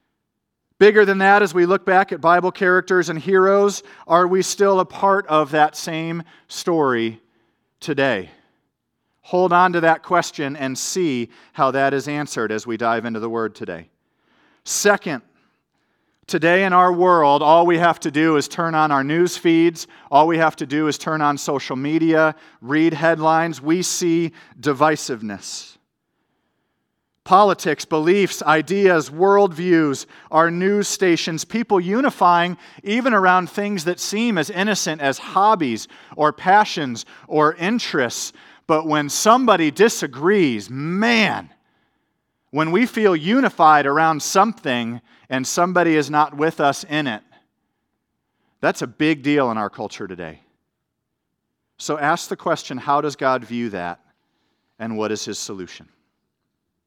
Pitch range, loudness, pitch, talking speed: 140-185 Hz, -18 LUFS, 160 Hz, 140 wpm